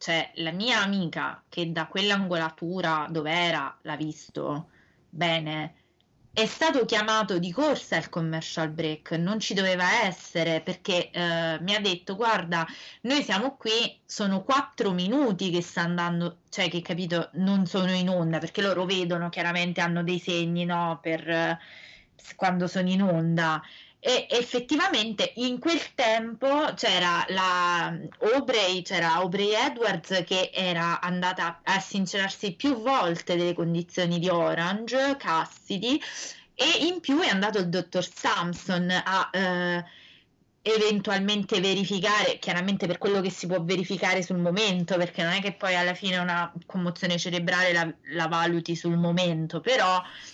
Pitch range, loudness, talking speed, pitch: 170-200 Hz, -26 LUFS, 145 wpm, 180 Hz